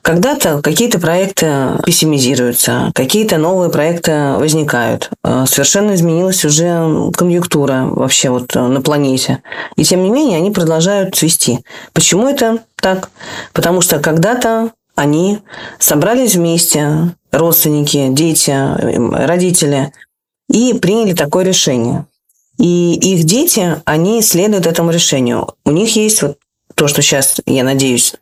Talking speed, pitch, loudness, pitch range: 115 wpm, 165 Hz, -11 LUFS, 145-185 Hz